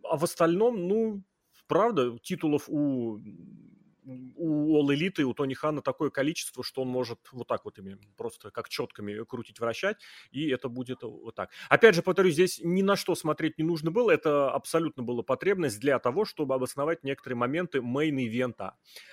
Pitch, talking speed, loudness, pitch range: 140 Hz, 170 wpm, -28 LUFS, 125-165 Hz